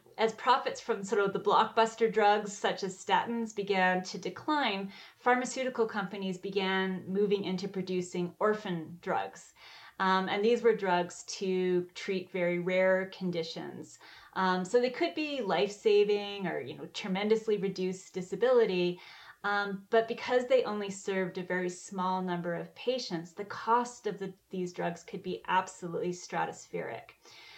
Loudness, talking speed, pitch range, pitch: -31 LUFS, 145 wpm, 185-220 Hz, 195 Hz